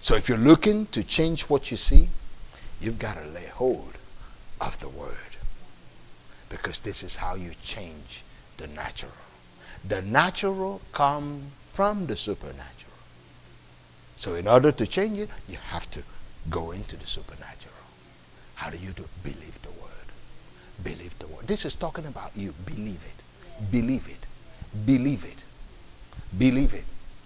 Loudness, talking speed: -27 LUFS, 150 wpm